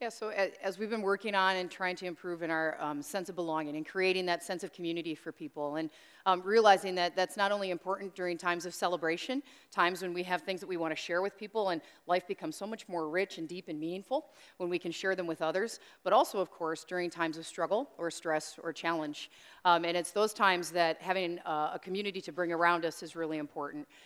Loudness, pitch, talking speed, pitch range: -33 LUFS, 180 Hz, 240 wpm, 165-190 Hz